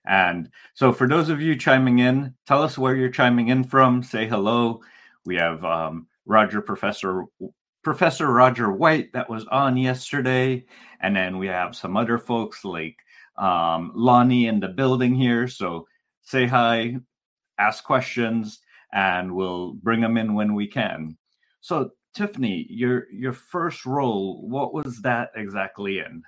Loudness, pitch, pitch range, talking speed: -22 LUFS, 120 Hz, 100-130 Hz, 155 wpm